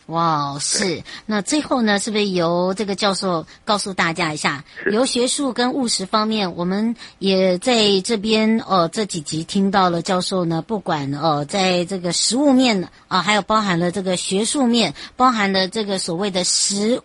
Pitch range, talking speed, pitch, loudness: 175-220 Hz, 260 characters per minute, 195 Hz, -19 LUFS